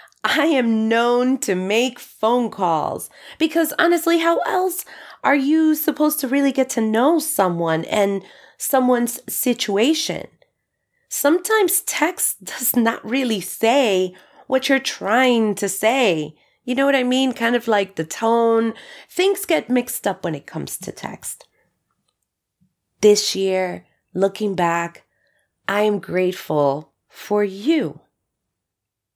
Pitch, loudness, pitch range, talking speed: 230 Hz, -19 LUFS, 200-280 Hz, 130 wpm